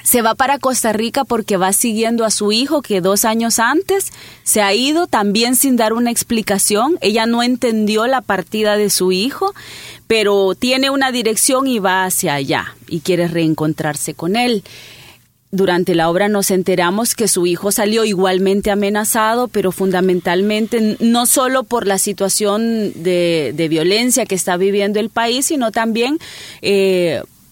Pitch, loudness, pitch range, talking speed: 210 Hz, -15 LUFS, 185-235 Hz, 160 wpm